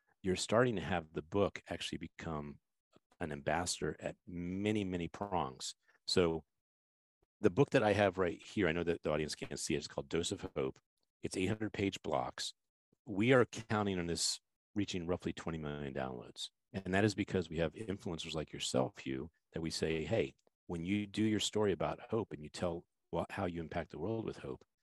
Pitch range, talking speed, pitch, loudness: 80-100 Hz, 195 wpm, 85 Hz, -37 LUFS